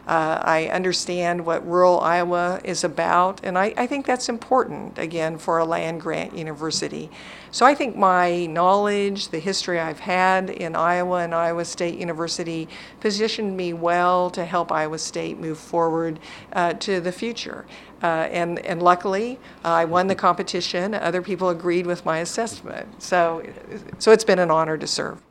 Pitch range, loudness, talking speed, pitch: 165-190 Hz, -22 LUFS, 170 wpm, 175 Hz